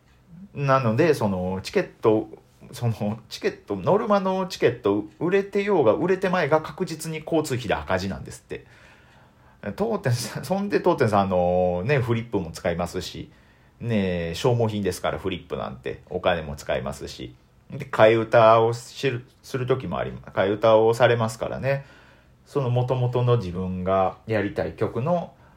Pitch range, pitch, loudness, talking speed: 95-140 Hz, 115 Hz, -23 LUFS, 315 characters per minute